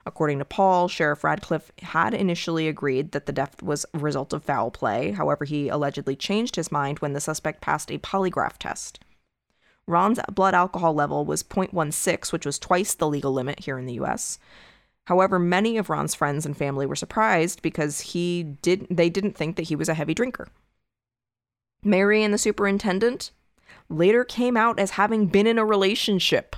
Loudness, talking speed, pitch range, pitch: -24 LUFS, 180 wpm, 145-195 Hz, 165 Hz